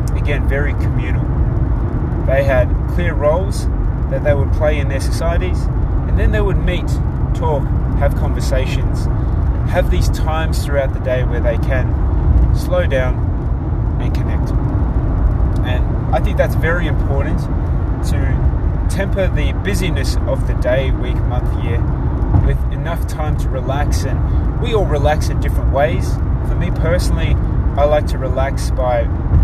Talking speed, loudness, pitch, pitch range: 145 wpm, -17 LUFS, 85 Hz, 70-95 Hz